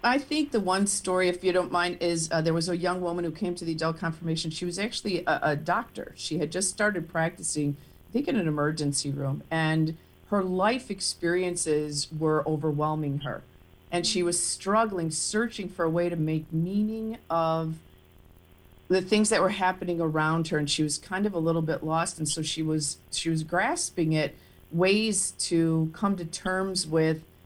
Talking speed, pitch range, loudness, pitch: 190 wpm, 155-185 Hz, -27 LUFS, 170 Hz